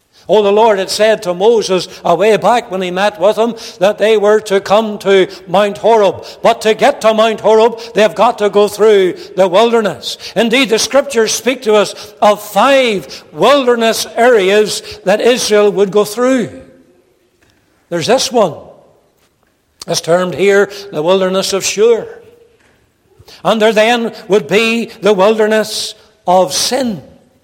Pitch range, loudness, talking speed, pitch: 195-230 Hz, -11 LUFS, 155 wpm, 215 Hz